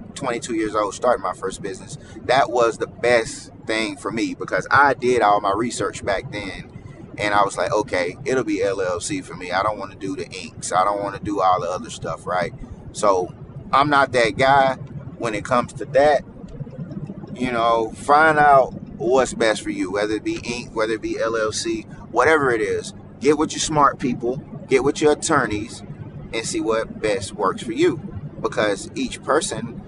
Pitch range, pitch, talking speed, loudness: 110-165 Hz, 130 Hz, 195 wpm, -21 LUFS